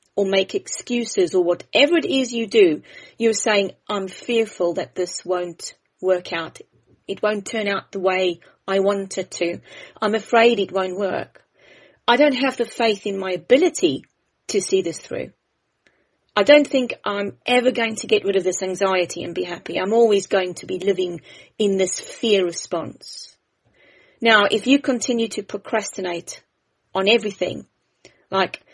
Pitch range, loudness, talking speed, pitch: 185-230 Hz, -20 LUFS, 165 wpm, 205 Hz